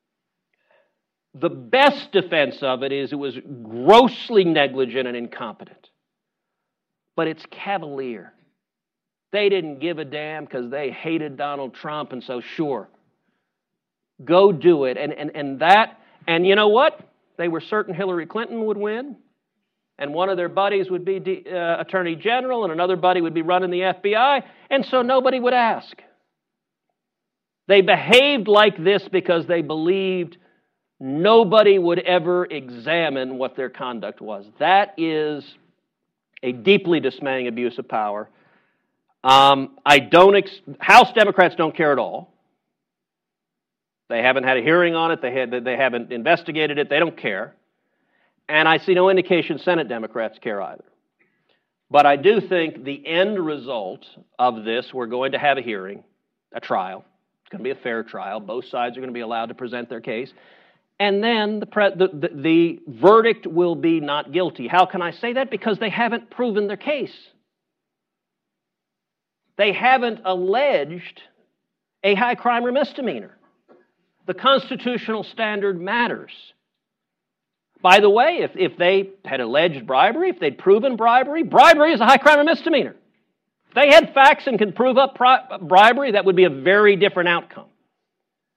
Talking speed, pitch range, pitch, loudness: 160 wpm, 150-210 Hz, 185 Hz, -18 LUFS